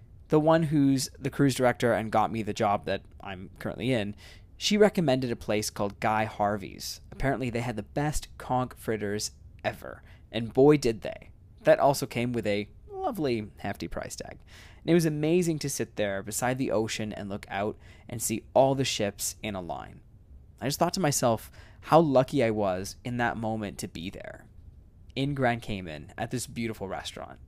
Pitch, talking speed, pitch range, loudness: 110 Hz, 190 wpm, 100-130 Hz, -28 LUFS